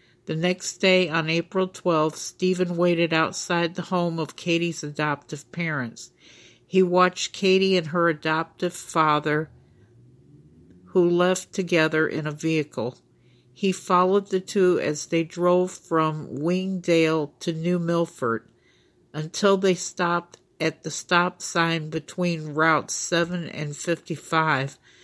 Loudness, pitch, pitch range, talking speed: -24 LUFS, 170 Hz, 155-180 Hz, 125 wpm